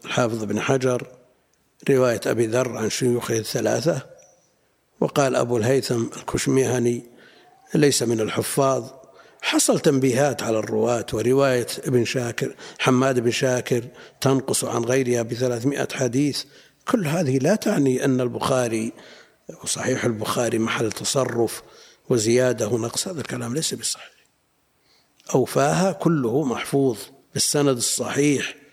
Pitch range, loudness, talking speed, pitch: 120-135 Hz, -22 LUFS, 110 wpm, 125 Hz